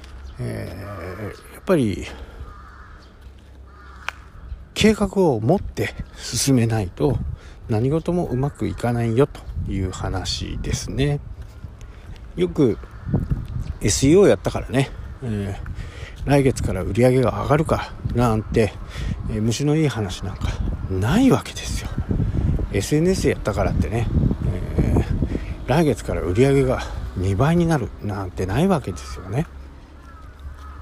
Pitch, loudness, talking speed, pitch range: 100 Hz, -22 LUFS, 230 characters per minute, 90-125 Hz